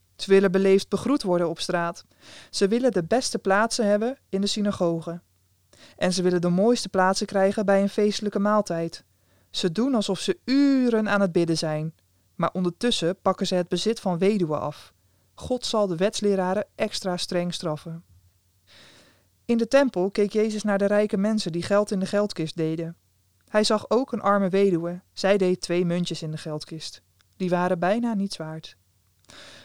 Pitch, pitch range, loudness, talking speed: 185 Hz, 165-205 Hz, -24 LUFS, 170 wpm